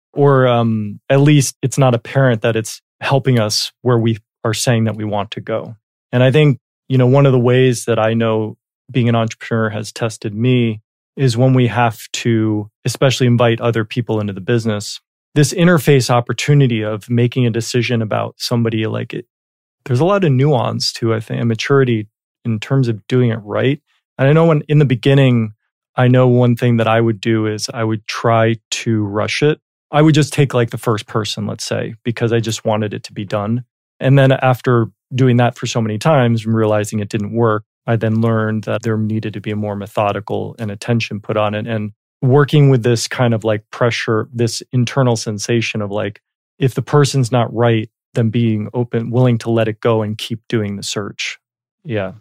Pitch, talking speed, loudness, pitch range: 115 Hz, 205 wpm, -16 LUFS, 110-130 Hz